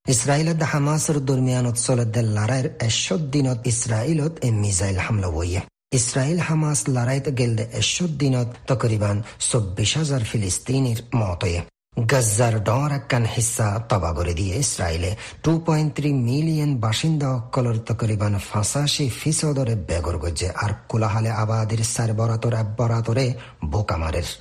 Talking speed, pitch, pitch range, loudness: 115 wpm, 120 Hz, 105-135 Hz, -22 LUFS